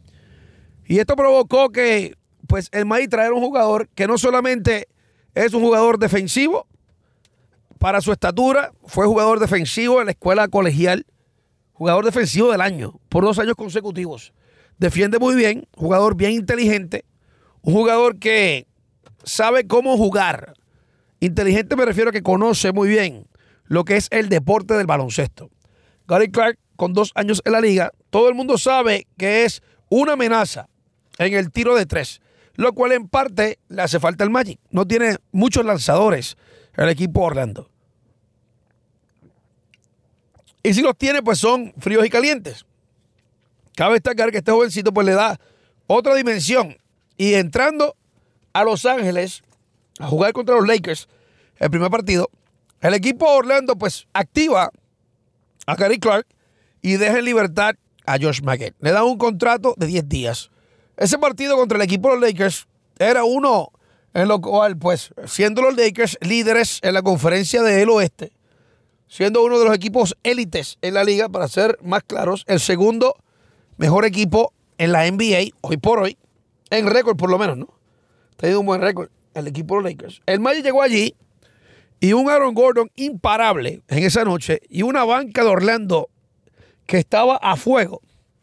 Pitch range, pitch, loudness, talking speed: 170-235 Hz, 205 Hz, -18 LUFS, 160 wpm